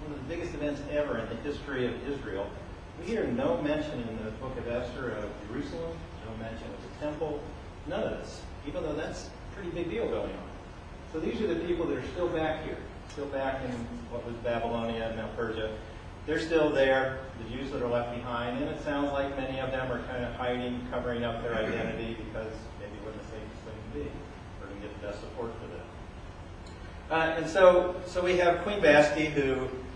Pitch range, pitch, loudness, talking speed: 110-145 Hz, 120 Hz, -31 LUFS, 210 wpm